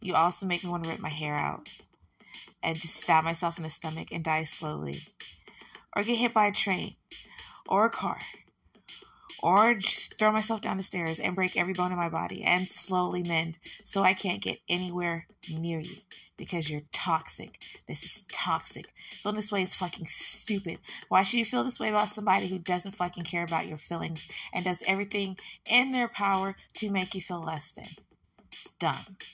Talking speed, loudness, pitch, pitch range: 190 wpm, -29 LUFS, 180 Hz, 165-200 Hz